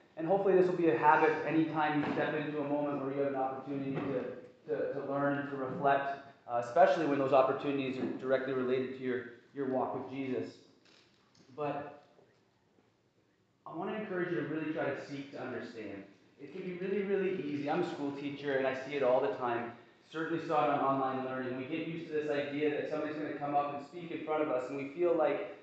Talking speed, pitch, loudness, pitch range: 225 wpm, 145 Hz, -34 LUFS, 130-155 Hz